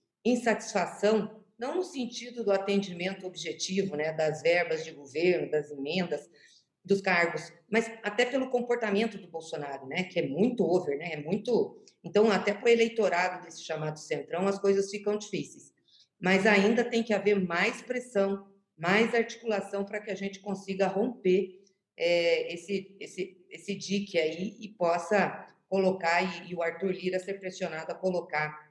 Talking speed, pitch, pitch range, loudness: 155 wpm, 195 Hz, 175-215 Hz, -29 LUFS